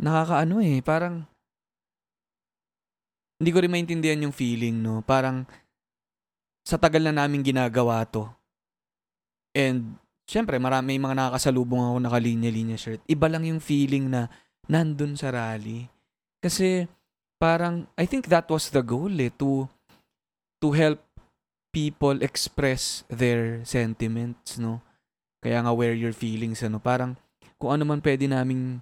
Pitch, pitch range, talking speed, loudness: 130 Hz, 120-155 Hz, 130 wpm, -25 LUFS